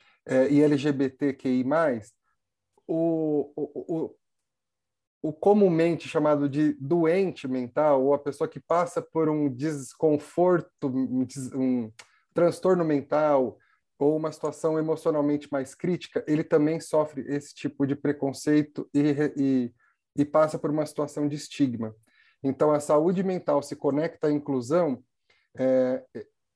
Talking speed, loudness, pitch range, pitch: 120 wpm, -26 LUFS, 135-160 Hz, 150 Hz